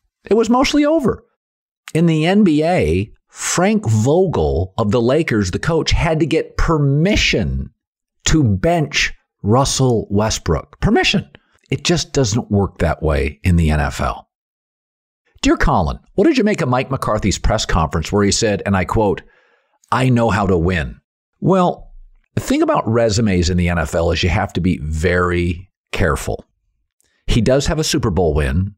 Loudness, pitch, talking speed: -17 LUFS, 105 Hz, 160 wpm